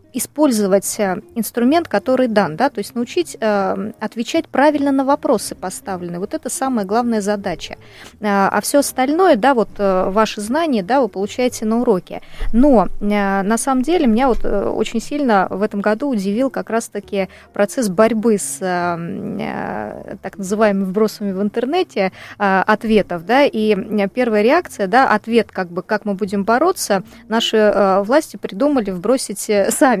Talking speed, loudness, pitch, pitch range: 150 wpm, -17 LUFS, 220 Hz, 200-255 Hz